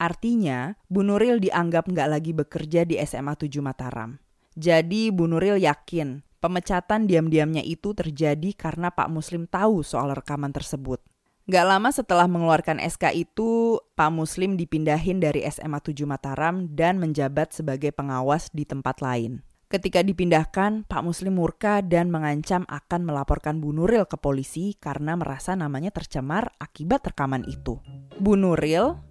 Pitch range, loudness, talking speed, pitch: 145-185 Hz, -24 LUFS, 140 wpm, 165 Hz